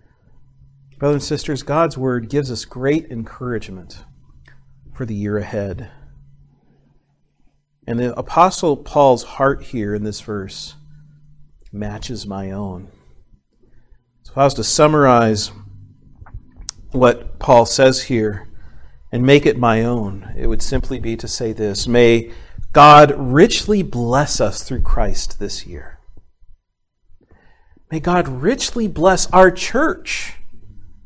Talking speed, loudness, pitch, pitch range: 120 wpm, -16 LUFS, 120 Hz, 100-140 Hz